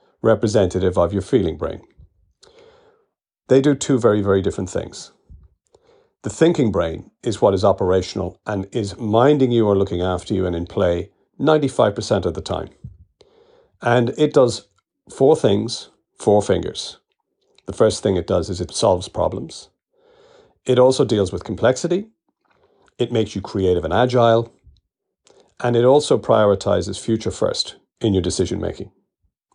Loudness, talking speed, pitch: -19 LUFS, 145 wpm, 120 Hz